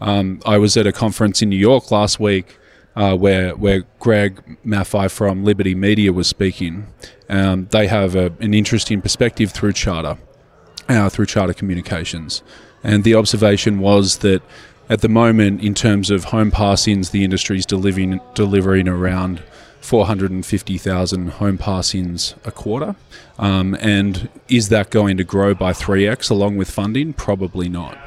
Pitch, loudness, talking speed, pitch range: 100 Hz, -17 LUFS, 155 wpm, 95-105 Hz